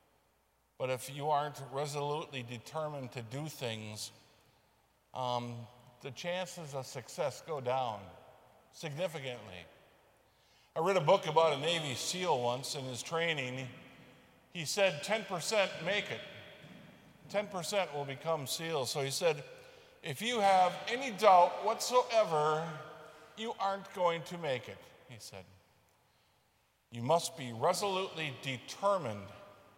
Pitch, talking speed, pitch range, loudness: 155 Hz, 120 wpm, 130-185 Hz, -34 LUFS